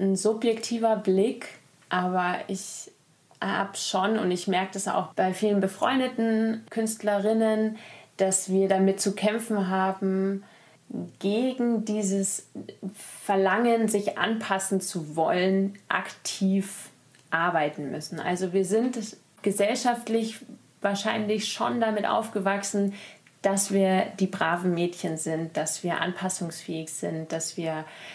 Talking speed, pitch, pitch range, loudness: 110 wpm, 195 Hz, 185-215 Hz, -27 LUFS